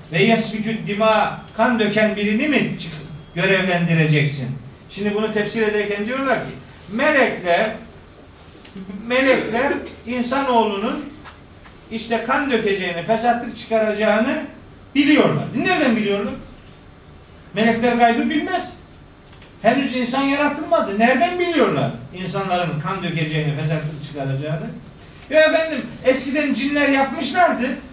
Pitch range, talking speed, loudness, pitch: 190-260 Hz, 90 wpm, -19 LUFS, 220 Hz